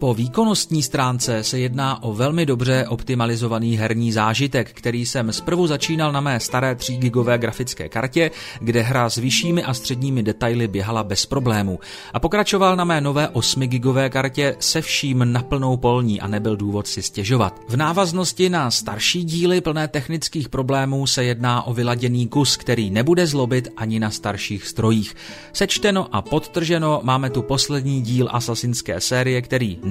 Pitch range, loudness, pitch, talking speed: 115-145 Hz, -20 LUFS, 125 Hz, 160 wpm